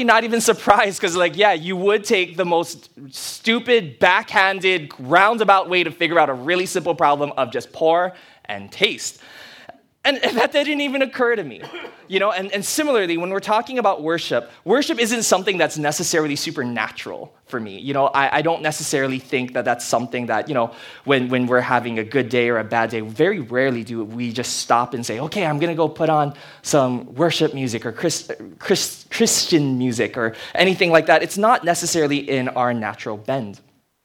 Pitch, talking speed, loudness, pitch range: 155 Hz, 190 wpm, -19 LUFS, 125-185 Hz